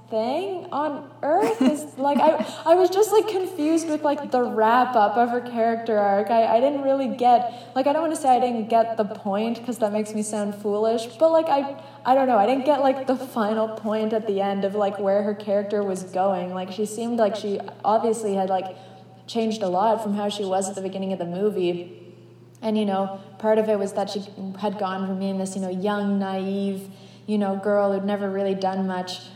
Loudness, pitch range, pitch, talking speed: -23 LUFS, 195-250 Hz, 215 Hz, 230 wpm